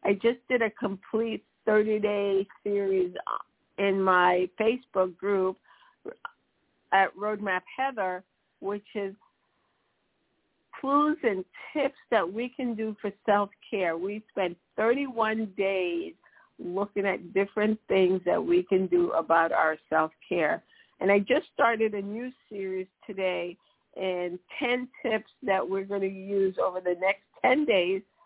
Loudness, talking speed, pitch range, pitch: -28 LUFS, 130 wpm, 185-225 Hz, 200 Hz